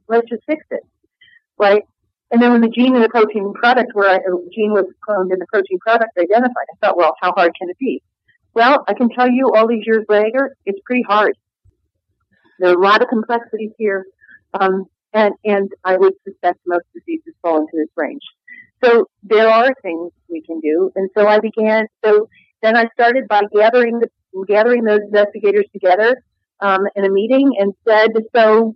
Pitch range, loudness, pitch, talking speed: 190-235 Hz, -15 LUFS, 215 Hz, 195 wpm